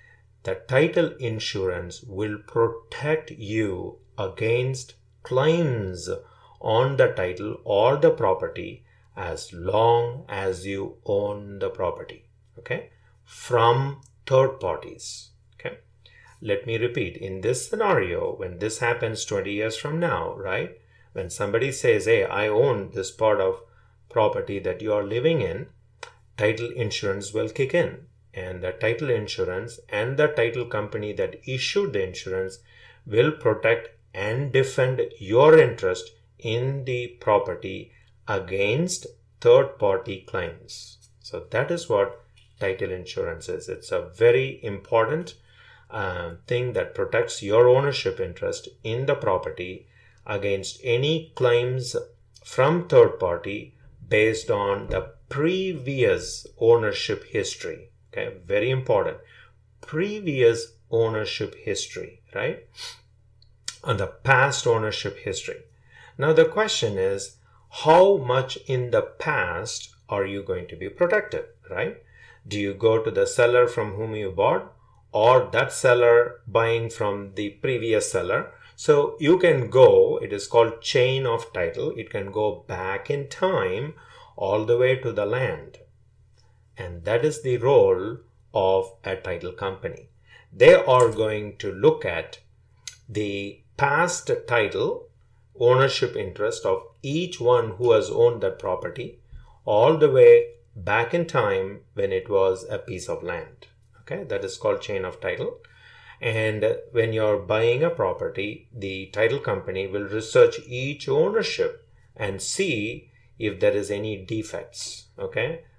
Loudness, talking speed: -23 LUFS, 135 wpm